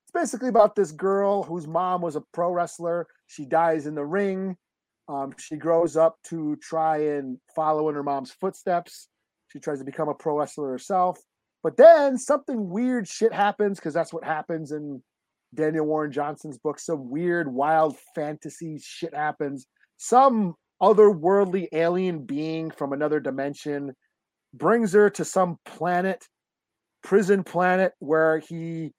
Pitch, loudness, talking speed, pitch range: 165 Hz, -24 LUFS, 150 wpm, 150-190 Hz